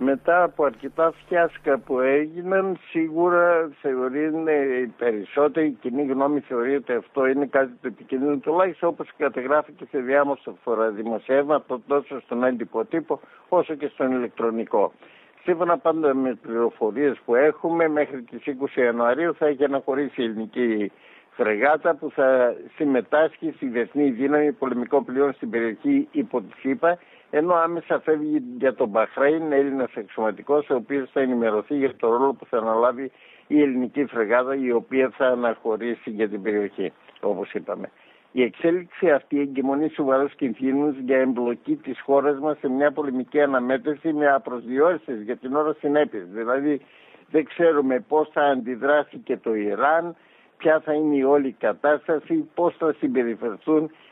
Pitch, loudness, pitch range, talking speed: 140 Hz, -23 LUFS, 125-155 Hz, 145 wpm